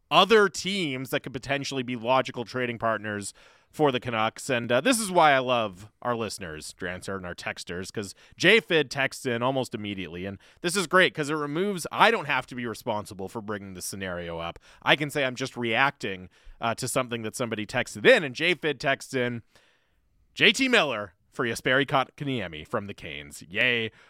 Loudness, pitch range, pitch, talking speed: -26 LUFS, 105-140 Hz, 125 Hz, 185 wpm